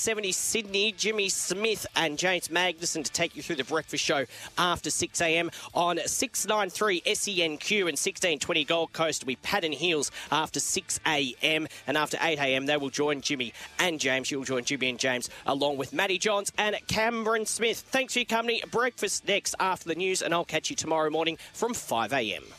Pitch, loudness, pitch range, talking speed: 170 Hz, -27 LUFS, 150-200 Hz, 180 wpm